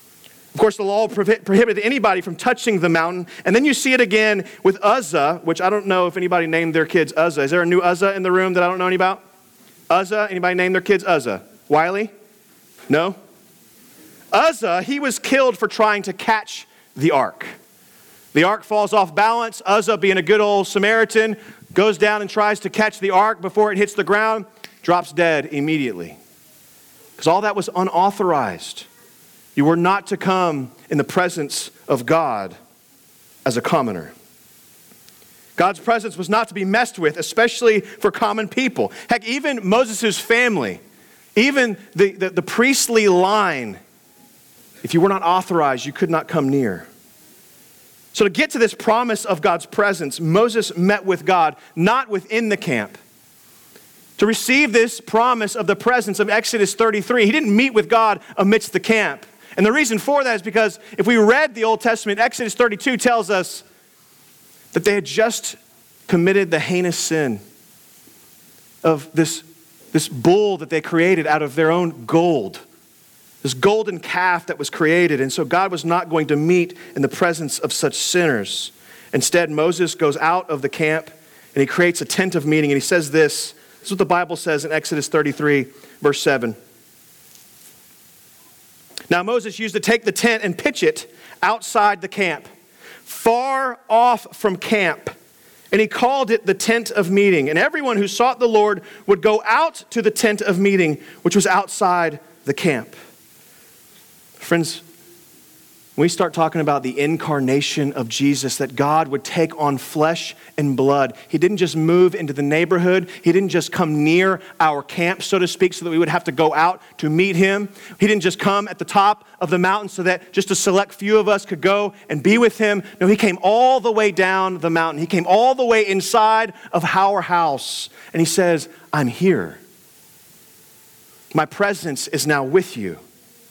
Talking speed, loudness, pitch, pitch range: 180 wpm, -18 LUFS, 190 Hz, 165-215 Hz